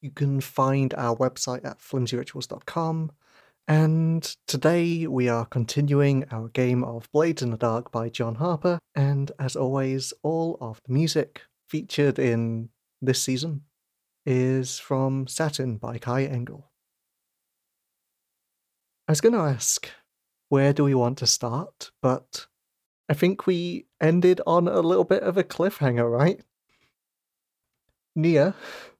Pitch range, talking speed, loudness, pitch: 120-155 Hz, 130 wpm, -25 LUFS, 135 Hz